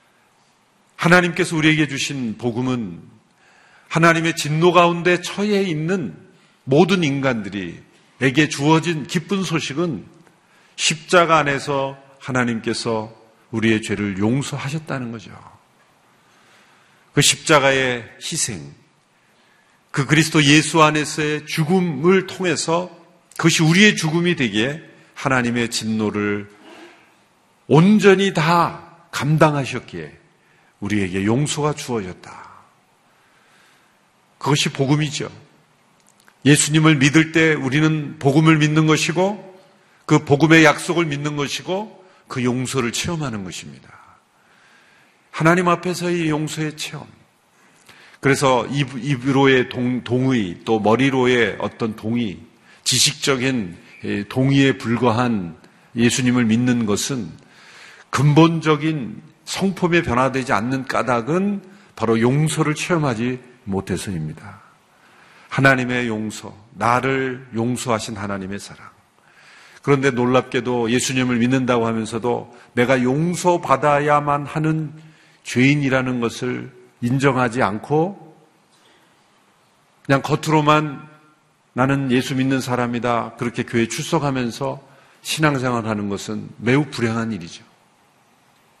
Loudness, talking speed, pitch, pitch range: -19 LUFS, 245 characters per minute, 140 Hz, 120-160 Hz